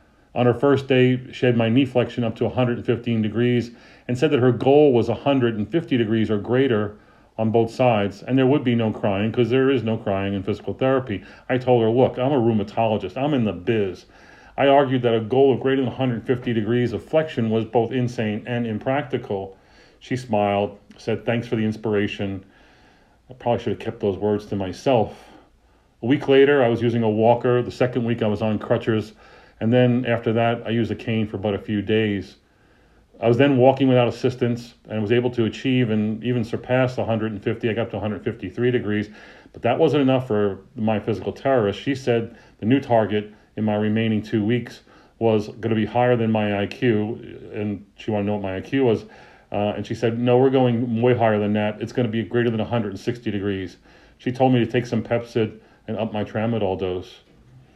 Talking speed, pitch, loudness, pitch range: 205 wpm, 115 Hz, -21 LUFS, 105-125 Hz